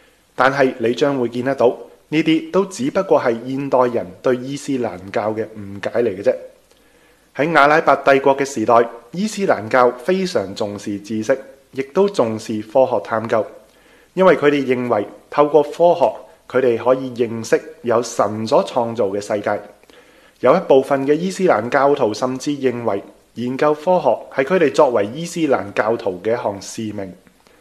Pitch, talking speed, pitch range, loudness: 130 Hz, 245 characters per minute, 115-150 Hz, -18 LUFS